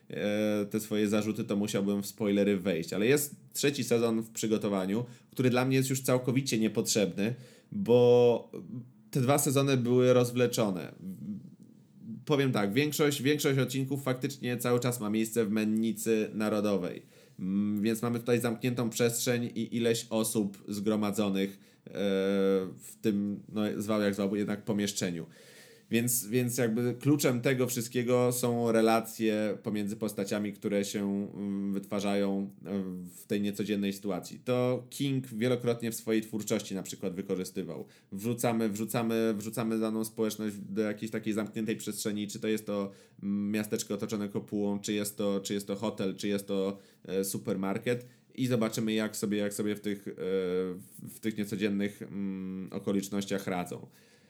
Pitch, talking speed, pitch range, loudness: 110 Hz, 135 wpm, 100-120 Hz, -31 LUFS